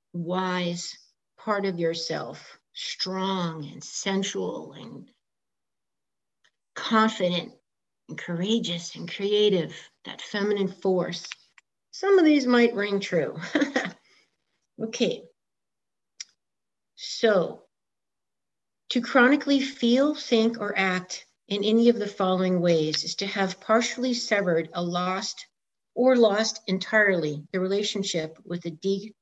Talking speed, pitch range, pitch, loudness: 105 wpm, 180-230 Hz, 200 Hz, -25 LUFS